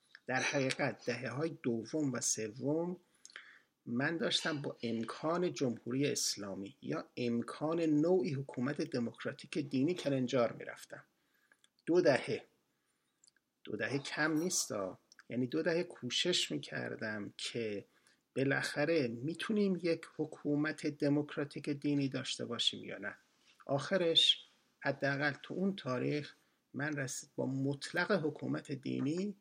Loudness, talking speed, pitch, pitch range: -36 LUFS, 110 wpm, 145 Hz, 130-160 Hz